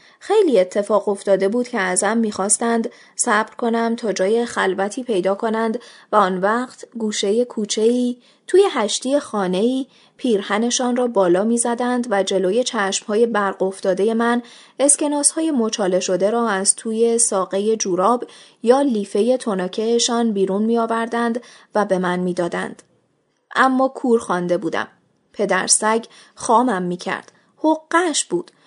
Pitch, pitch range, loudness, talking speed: 225 Hz, 195-245 Hz, -19 LUFS, 125 wpm